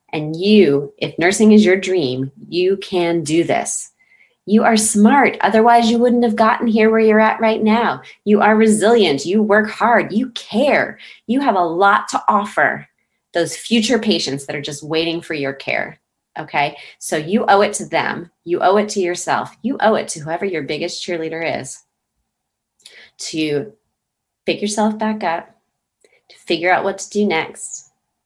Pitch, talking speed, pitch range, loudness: 200 Hz, 175 wpm, 165-220 Hz, -16 LUFS